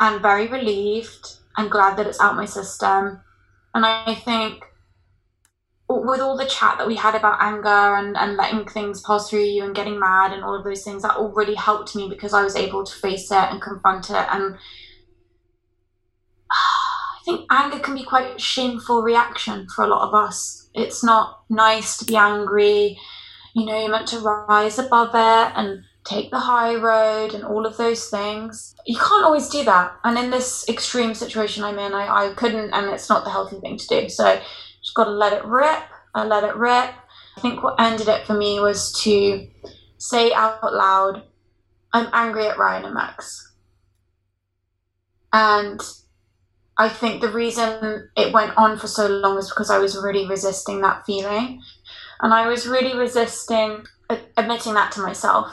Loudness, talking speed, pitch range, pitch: -20 LUFS, 185 wpm, 195-230 Hz, 210 Hz